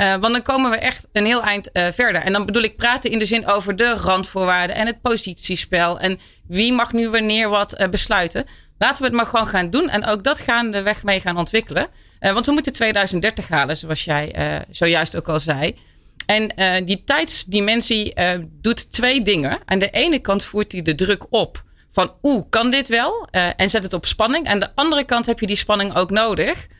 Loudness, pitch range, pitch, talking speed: -18 LUFS, 185-235 Hz, 210 Hz, 225 wpm